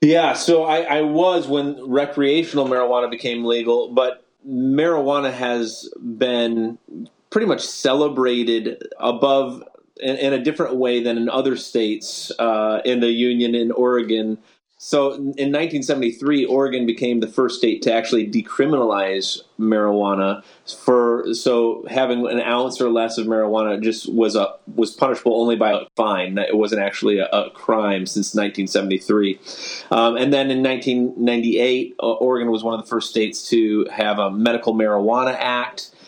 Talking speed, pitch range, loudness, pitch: 150 wpm, 115-130 Hz, -19 LUFS, 120 Hz